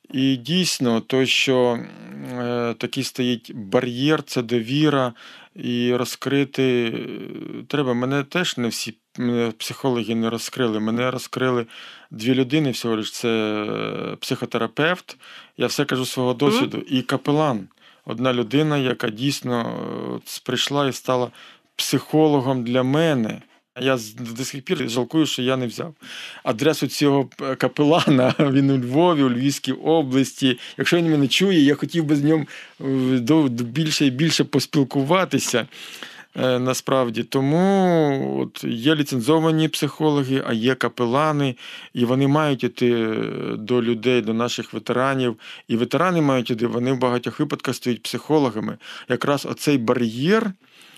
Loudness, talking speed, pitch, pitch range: -21 LUFS, 125 wpm, 130 Hz, 120-145 Hz